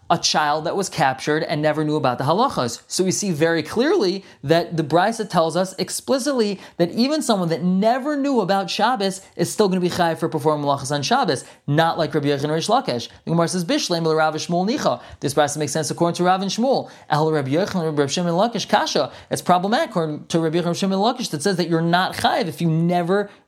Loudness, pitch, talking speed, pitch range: -20 LUFS, 170 Hz, 205 wpm, 160-195 Hz